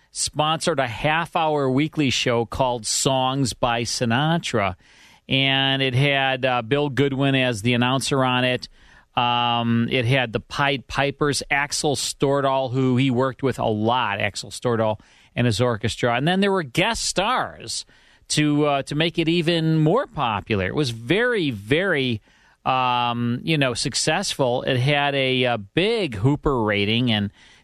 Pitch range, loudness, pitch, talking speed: 120-145 Hz, -21 LUFS, 130 Hz, 150 wpm